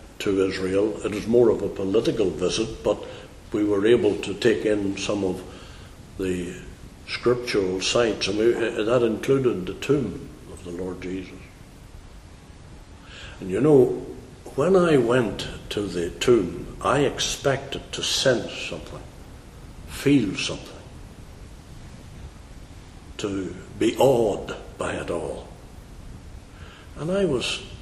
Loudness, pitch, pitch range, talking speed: -23 LUFS, 95 Hz, 90-100 Hz, 120 wpm